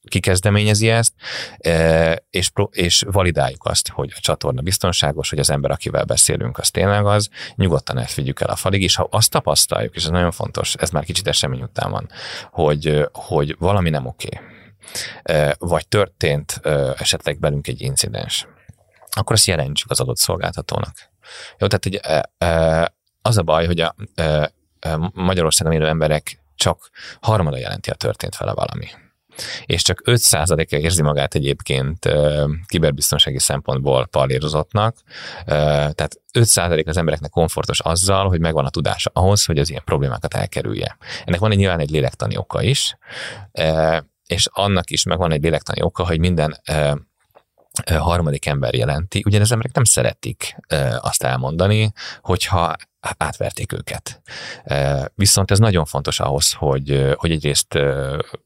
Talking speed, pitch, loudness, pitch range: 140 wpm, 80 Hz, -18 LUFS, 75-95 Hz